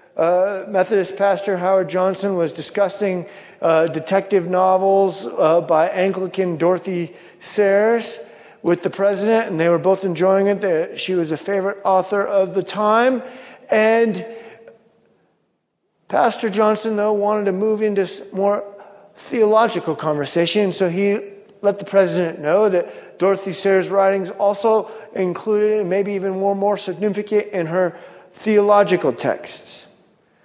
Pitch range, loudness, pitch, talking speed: 185-210 Hz, -18 LUFS, 195 Hz, 130 wpm